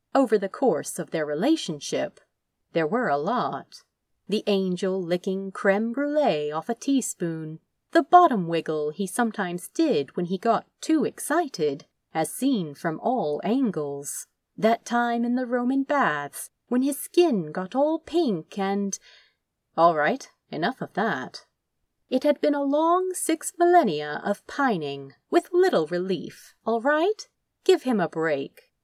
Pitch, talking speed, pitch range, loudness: 220 Hz, 145 wpm, 175-285 Hz, -25 LUFS